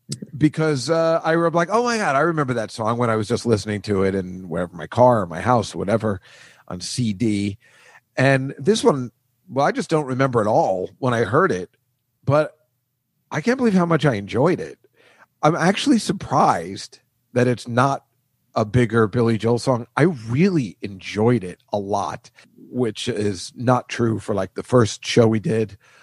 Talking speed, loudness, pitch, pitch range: 185 wpm, -20 LUFS, 125 Hz, 110-155 Hz